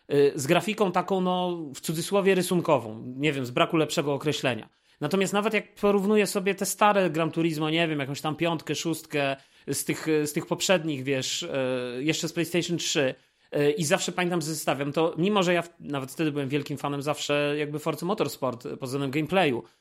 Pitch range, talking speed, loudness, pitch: 145-180 Hz, 175 wpm, -26 LUFS, 160 Hz